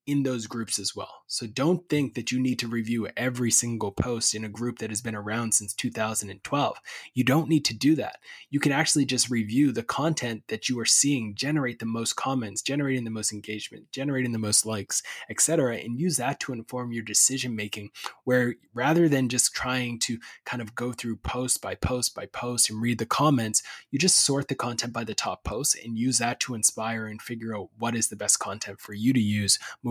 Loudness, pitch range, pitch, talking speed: -26 LUFS, 110-130 Hz, 120 Hz, 220 wpm